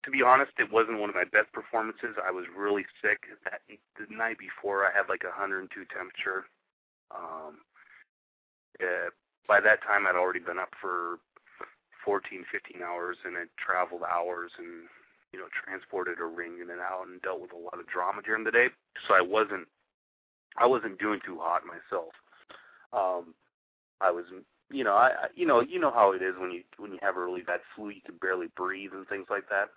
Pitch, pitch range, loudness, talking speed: 90 Hz, 85-100 Hz, -29 LUFS, 200 wpm